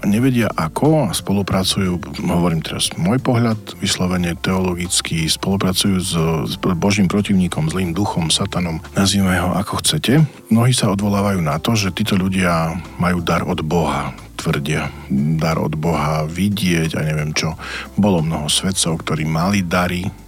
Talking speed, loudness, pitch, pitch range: 145 wpm, -18 LUFS, 90 Hz, 80-100 Hz